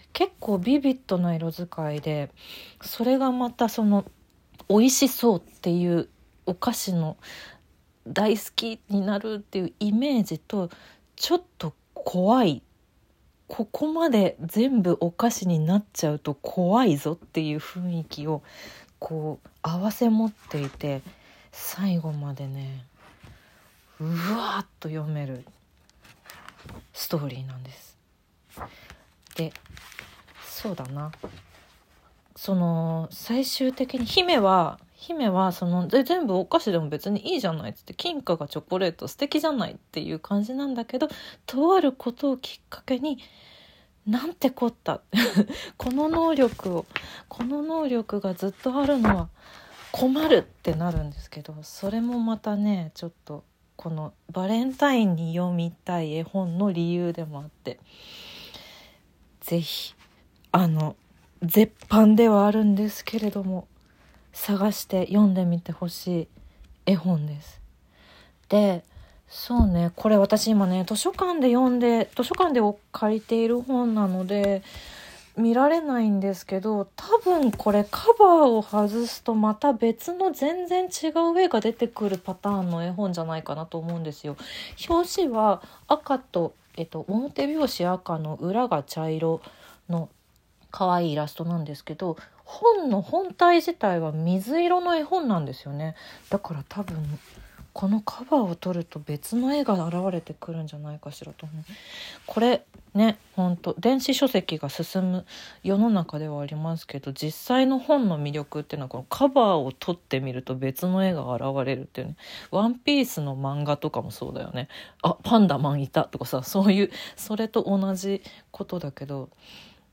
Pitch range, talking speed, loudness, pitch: 160-235 Hz, 285 characters per minute, -25 LUFS, 195 Hz